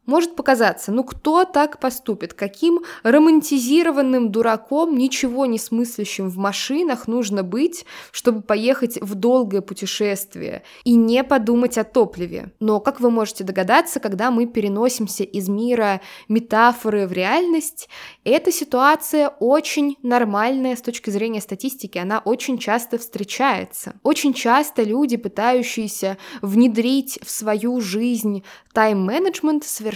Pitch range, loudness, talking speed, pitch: 215-275 Hz, -19 LUFS, 120 wpm, 240 Hz